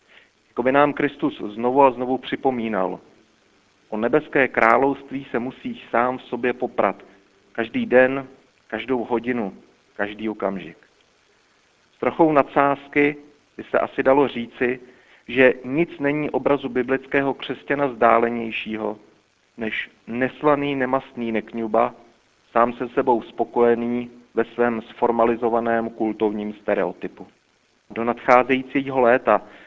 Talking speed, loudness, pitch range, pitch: 105 wpm, -21 LUFS, 115-135 Hz, 120 Hz